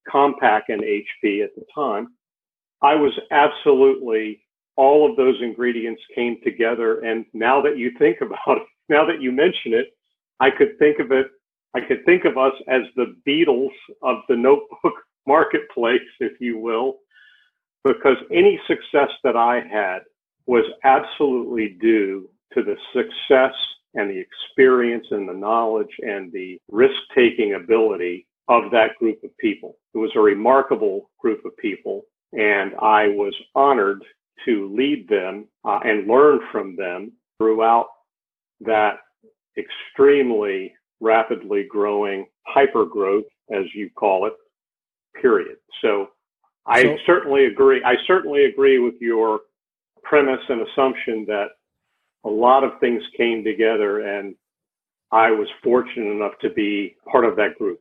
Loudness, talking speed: -19 LUFS, 140 wpm